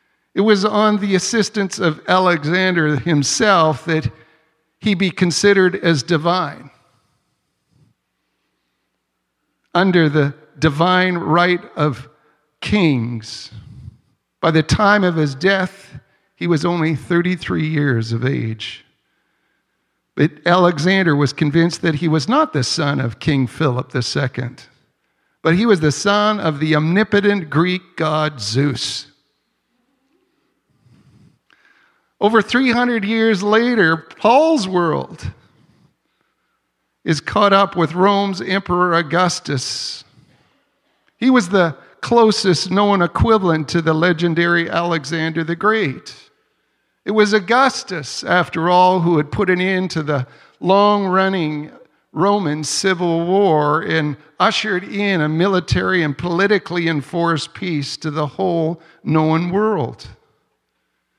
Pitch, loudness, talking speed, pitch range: 170 Hz, -17 LUFS, 110 wpm, 150-195 Hz